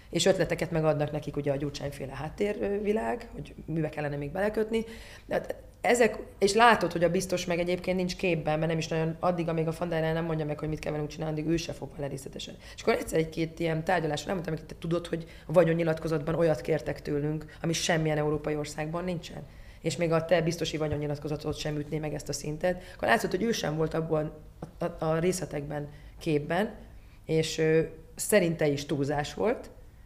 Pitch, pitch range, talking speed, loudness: 160 Hz, 150-175 Hz, 190 wpm, -29 LUFS